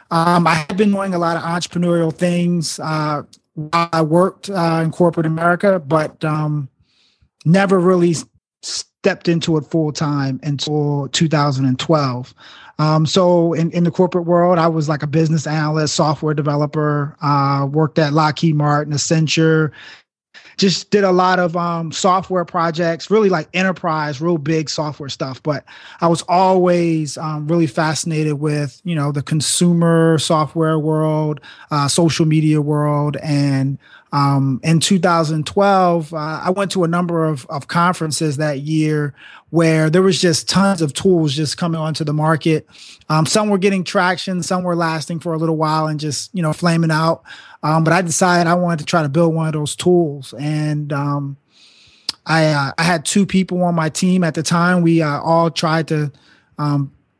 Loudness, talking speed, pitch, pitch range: -17 LUFS, 170 wpm, 160 Hz, 150-175 Hz